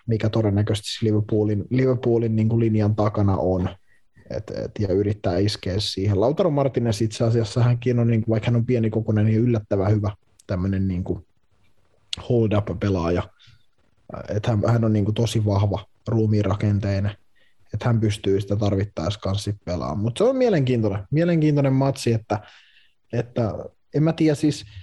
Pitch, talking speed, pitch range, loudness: 105 Hz, 145 wpm, 100-115 Hz, -22 LUFS